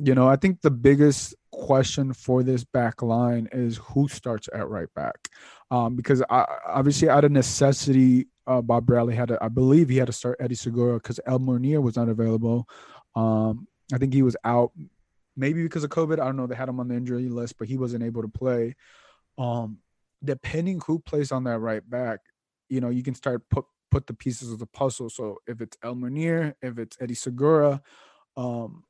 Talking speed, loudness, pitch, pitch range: 205 wpm, -24 LUFS, 125 Hz, 120-135 Hz